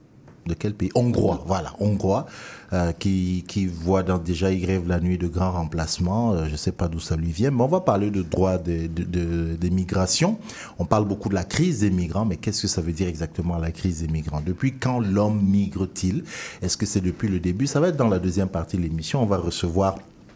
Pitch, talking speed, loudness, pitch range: 95 Hz, 235 wpm, -24 LUFS, 85-105 Hz